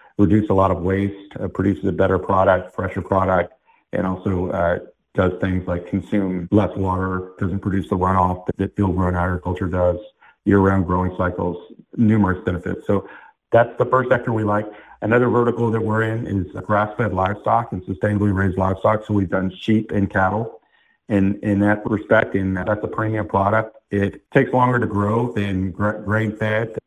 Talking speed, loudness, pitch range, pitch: 175 wpm, -20 LUFS, 95-110 Hz, 100 Hz